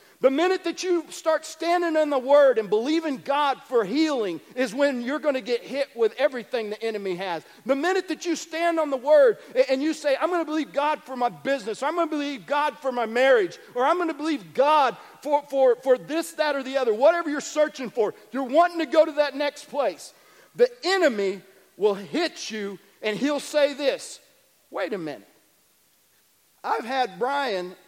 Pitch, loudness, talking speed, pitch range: 285 Hz, -24 LUFS, 205 wpm, 250-320 Hz